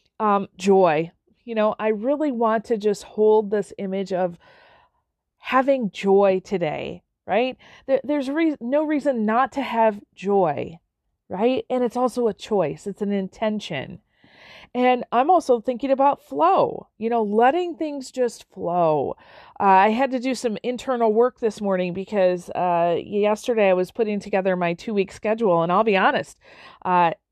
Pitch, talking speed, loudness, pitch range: 215 Hz, 160 wpm, -22 LUFS, 195-250 Hz